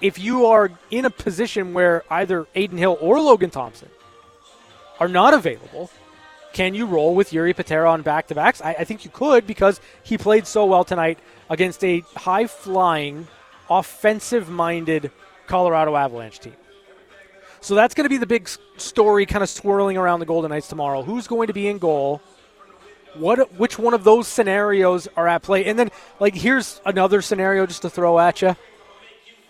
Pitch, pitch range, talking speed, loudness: 190 Hz, 170-215 Hz, 180 wpm, -19 LUFS